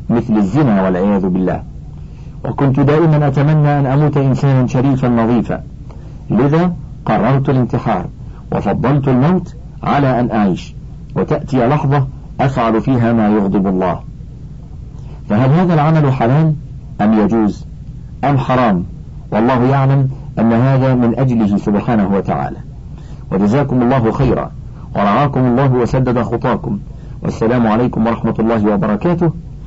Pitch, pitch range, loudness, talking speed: 130 Hz, 115-140 Hz, -14 LUFS, 110 wpm